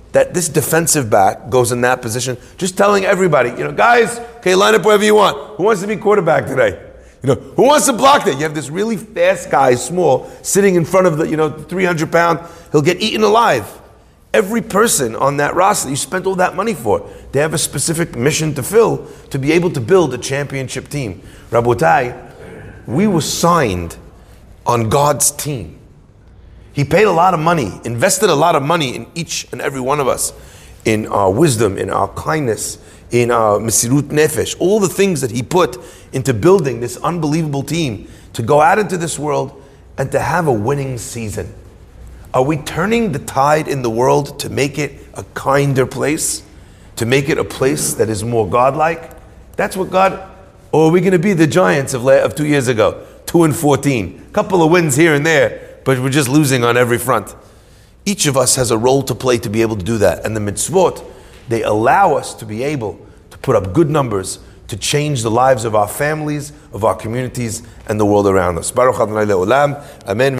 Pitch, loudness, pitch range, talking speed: 145 Hz, -15 LUFS, 120-175 Hz, 200 wpm